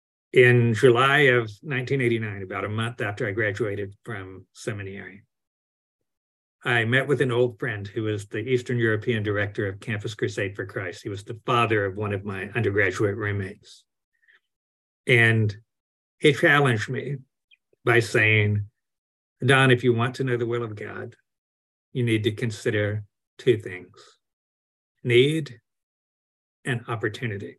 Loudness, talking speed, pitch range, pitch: -23 LUFS, 140 wpm, 100-125 Hz, 110 Hz